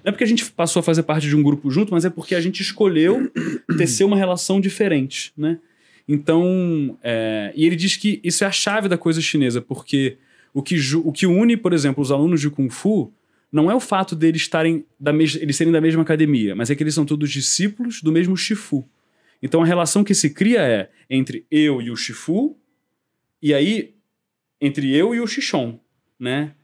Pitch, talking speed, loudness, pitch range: 160 Hz, 205 wpm, -19 LUFS, 145-190 Hz